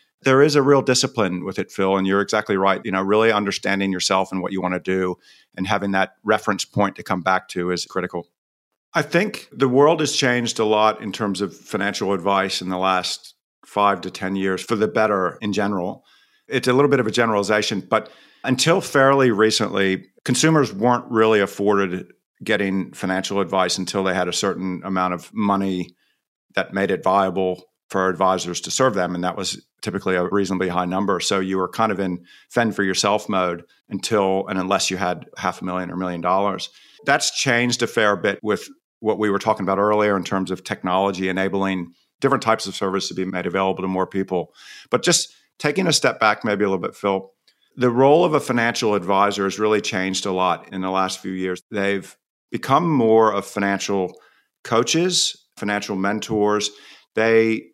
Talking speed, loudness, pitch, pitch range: 195 wpm, -20 LUFS, 100 Hz, 95-110 Hz